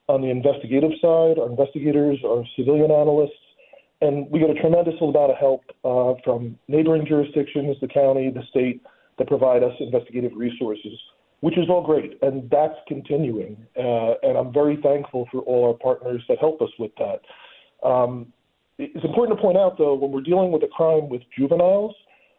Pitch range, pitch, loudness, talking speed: 125-155 Hz, 145 Hz, -21 LUFS, 175 wpm